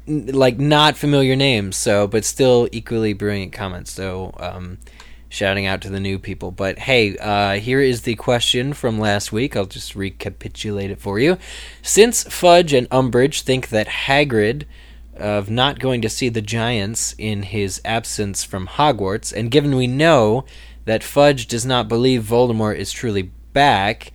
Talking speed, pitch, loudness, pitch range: 165 wpm, 110 Hz, -18 LUFS, 100-130 Hz